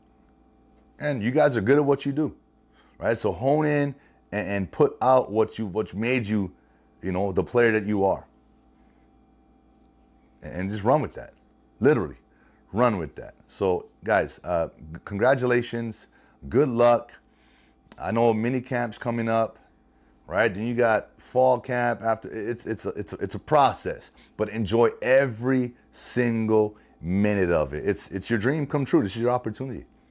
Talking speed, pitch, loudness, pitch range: 165 wpm, 115 Hz, -25 LUFS, 105-125 Hz